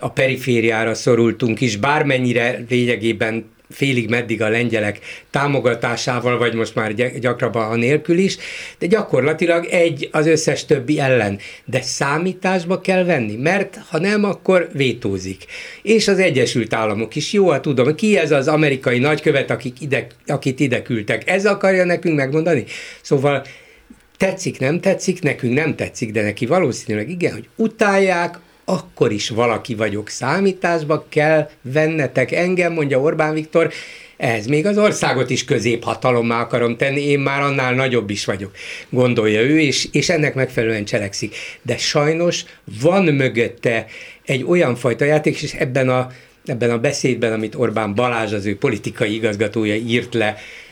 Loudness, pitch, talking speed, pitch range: -18 LUFS, 135 Hz, 145 wpm, 120-160 Hz